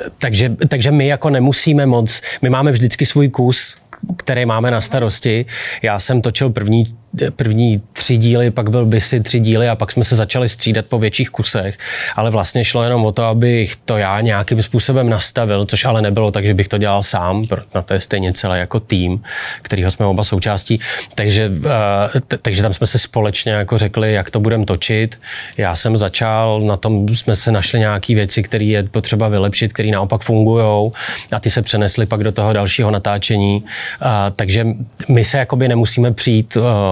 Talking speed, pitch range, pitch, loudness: 190 wpm, 105-120 Hz, 110 Hz, -14 LUFS